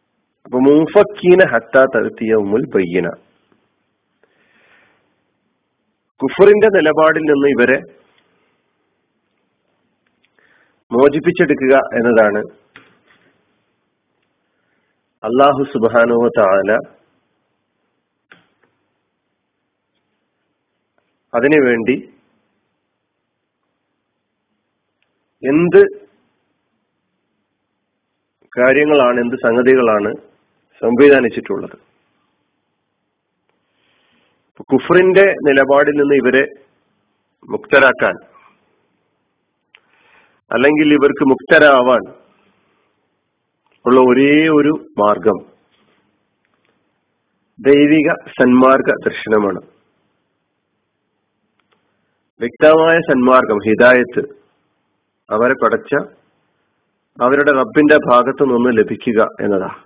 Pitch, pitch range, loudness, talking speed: 140 Hz, 125-150 Hz, -13 LUFS, 45 wpm